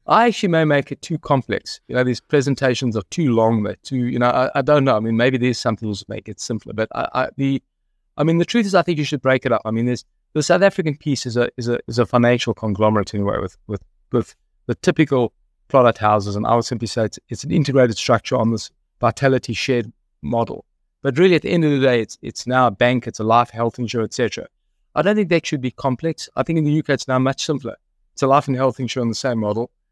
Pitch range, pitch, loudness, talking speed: 115-145 Hz, 125 Hz, -19 LUFS, 260 wpm